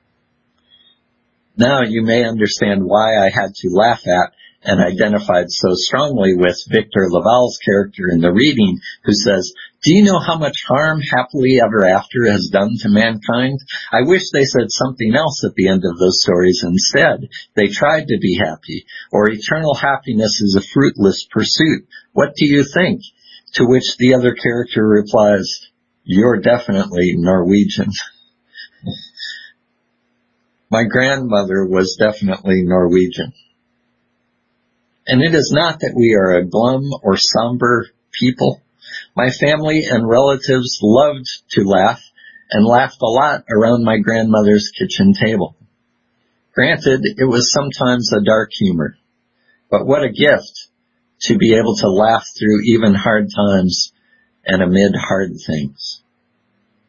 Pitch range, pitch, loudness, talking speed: 100-130 Hz, 115 Hz, -14 LUFS, 140 wpm